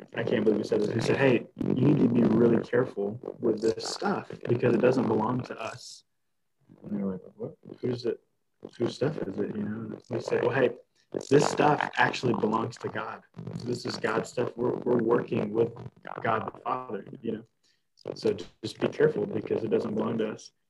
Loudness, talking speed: -28 LUFS, 200 wpm